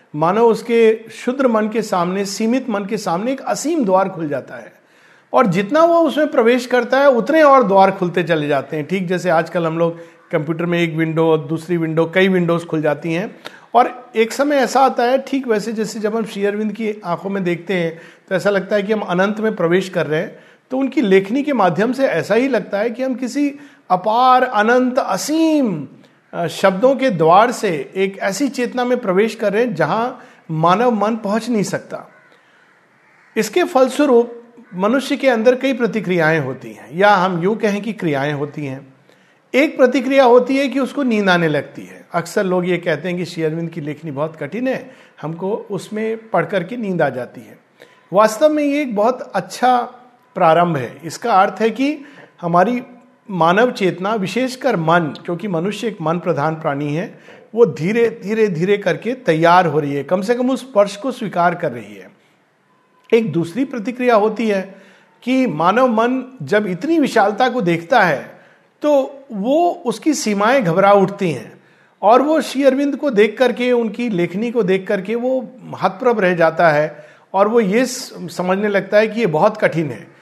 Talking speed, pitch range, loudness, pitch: 185 wpm, 175-250 Hz, -17 LUFS, 210 Hz